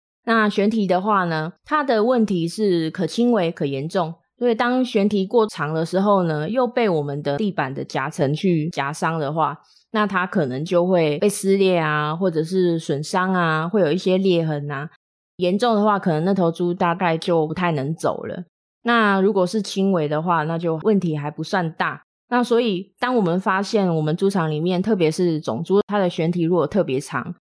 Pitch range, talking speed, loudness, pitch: 160-205 Hz, 280 characters per minute, -21 LUFS, 180 Hz